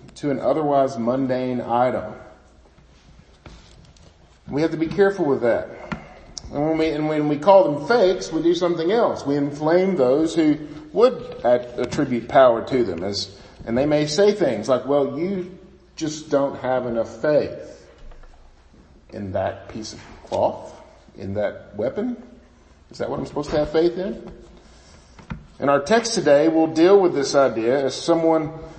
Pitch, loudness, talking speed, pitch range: 150 Hz, -20 LUFS, 160 wpm, 130-170 Hz